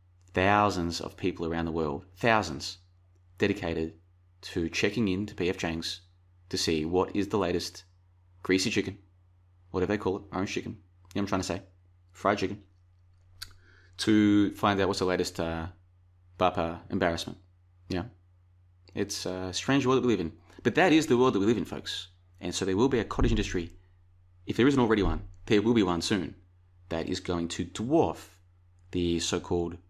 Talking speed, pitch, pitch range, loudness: 180 wpm, 90 Hz, 90-95 Hz, -29 LUFS